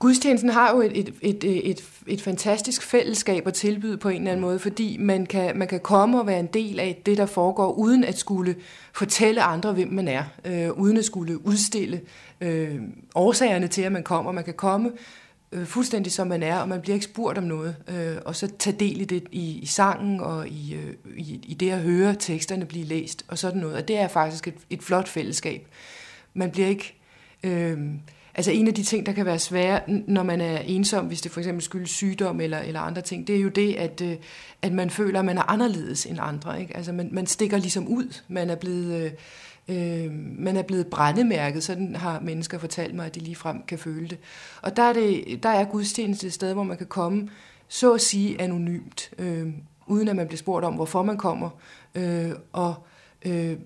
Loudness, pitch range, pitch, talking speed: -25 LUFS, 170-200 Hz, 185 Hz, 215 wpm